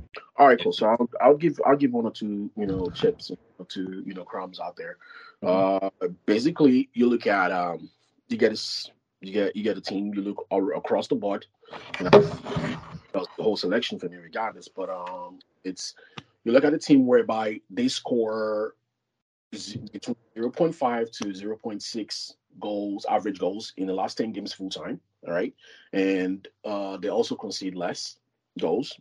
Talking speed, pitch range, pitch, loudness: 185 wpm, 95-140 Hz, 105 Hz, -26 LUFS